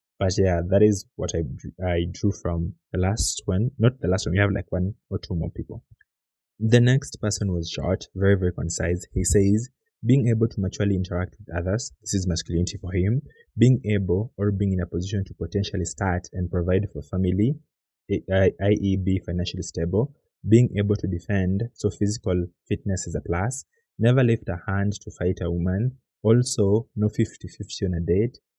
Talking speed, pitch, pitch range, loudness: 190 wpm, 100 Hz, 90-110 Hz, -24 LUFS